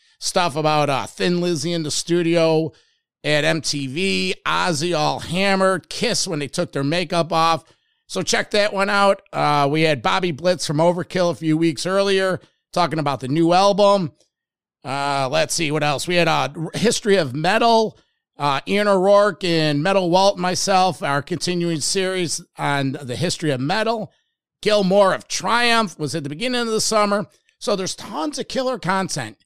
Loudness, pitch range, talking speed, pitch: -19 LUFS, 155-195 Hz, 175 wpm, 175 Hz